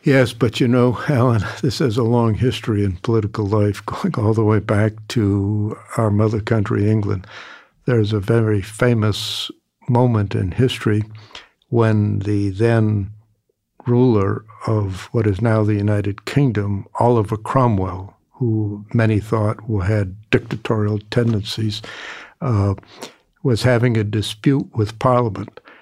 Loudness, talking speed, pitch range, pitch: -19 LUFS, 130 wpm, 105-120 Hz, 110 Hz